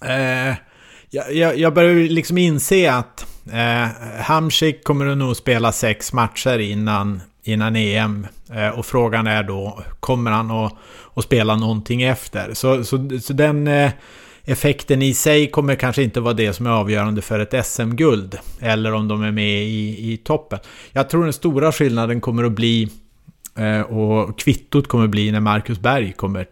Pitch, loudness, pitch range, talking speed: 115 Hz, -18 LUFS, 110-135 Hz, 170 wpm